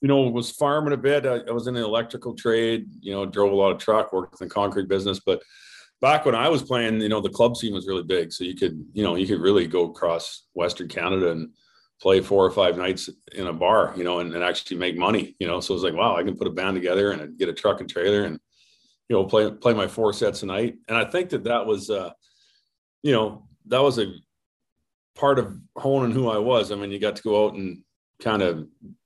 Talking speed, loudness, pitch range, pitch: 255 wpm, -23 LUFS, 95-130 Hz, 110 Hz